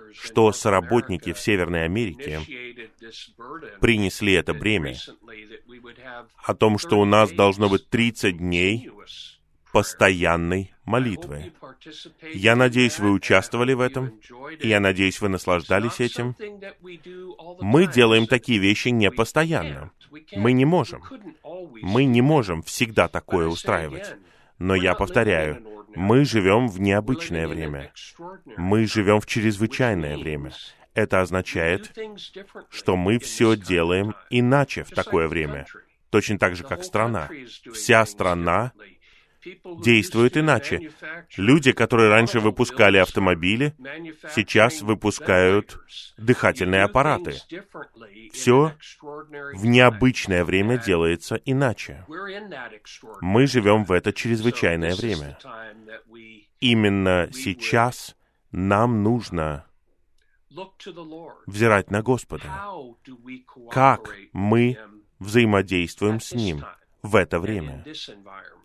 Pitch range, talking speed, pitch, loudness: 95-125 Hz, 100 wpm, 110 Hz, -21 LUFS